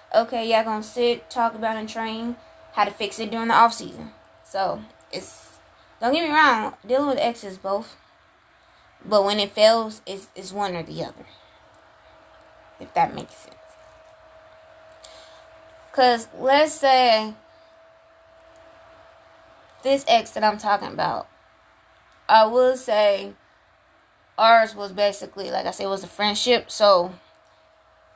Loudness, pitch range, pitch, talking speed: -21 LUFS, 210-315 Hz, 230 Hz, 135 wpm